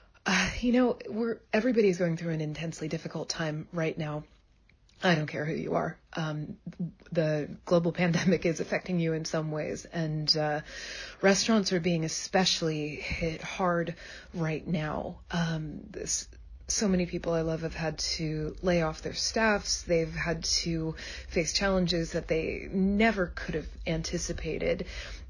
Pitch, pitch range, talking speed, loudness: 170 Hz, 155-185 Hz, 150 wpm, -30 LUFS